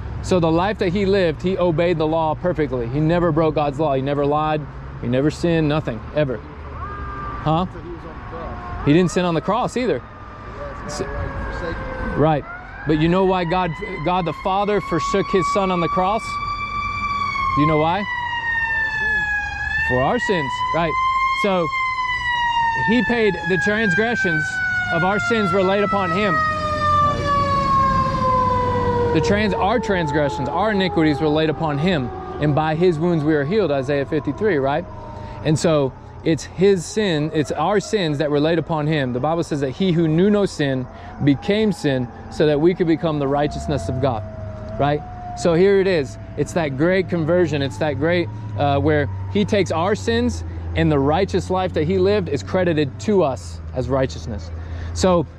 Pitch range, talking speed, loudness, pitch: 140-195 Hz, 165 wpm, -20 LUFS, 160 Hz